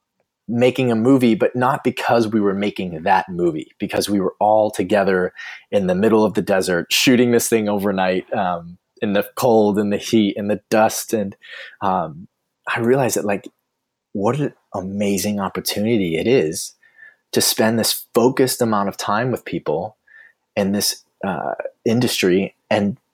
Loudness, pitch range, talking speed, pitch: -19 LUFS, 100-115 Hz, 160 wpm, 105 Hz